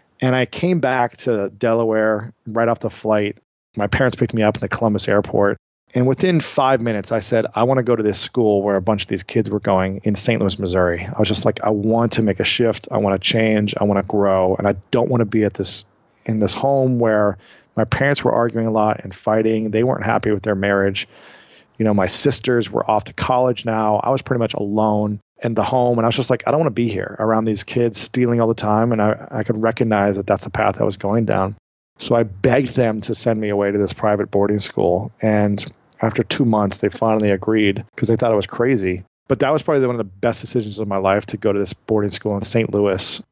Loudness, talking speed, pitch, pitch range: -18 LUFS, 255 wpm, 110 Hz, 100-120 Hz